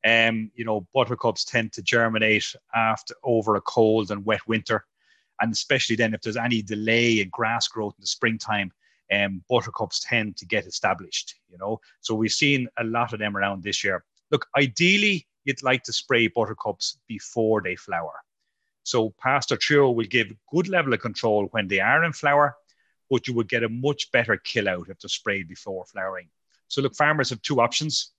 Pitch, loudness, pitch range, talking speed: 115 Hz, -24 LUFS, 110-125 Hz, 190 wpm